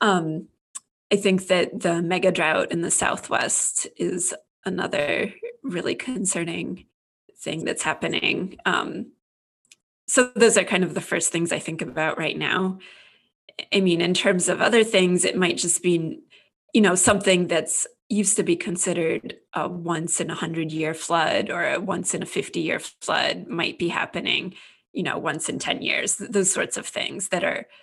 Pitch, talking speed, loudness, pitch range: 180 Hz, 170 wpm, -23 LUFS, 170-200 Hz